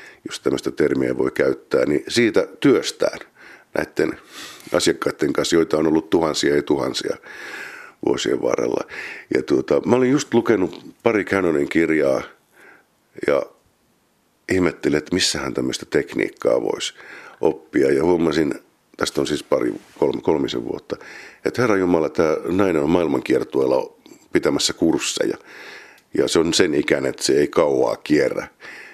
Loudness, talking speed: -20 LUFS, 135 wpm